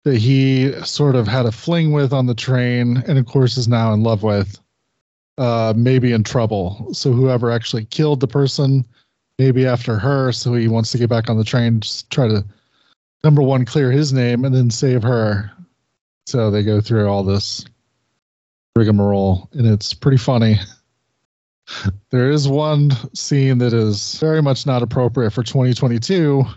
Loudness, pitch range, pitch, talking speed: -17 LUFS, 110-135 Hz, 125 Hz, 170 wpm